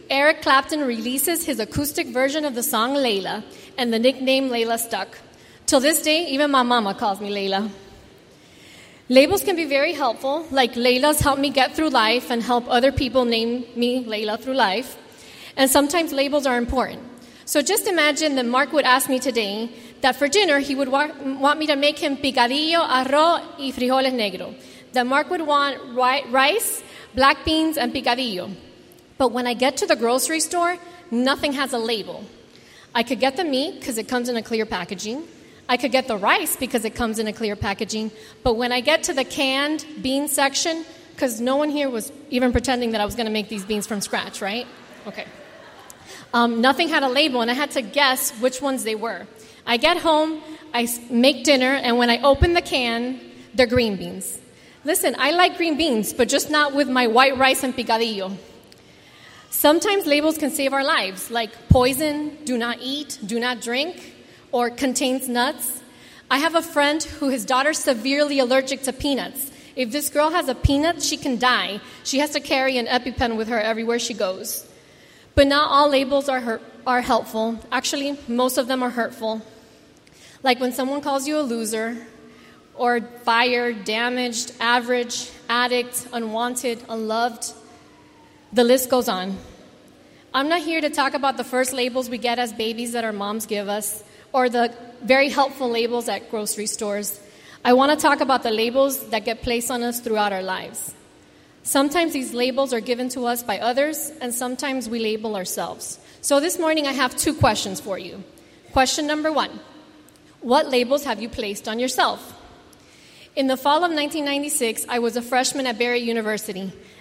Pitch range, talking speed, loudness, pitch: 235-285 Hz, 185 wpm, -21 LUFS, 255 Hz